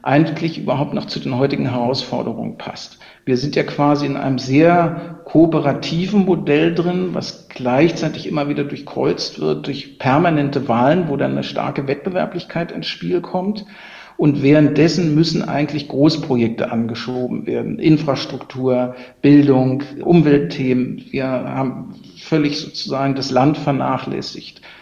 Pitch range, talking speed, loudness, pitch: 130-165 Hz, 125 wpm, -18 LUFS, 145 Hz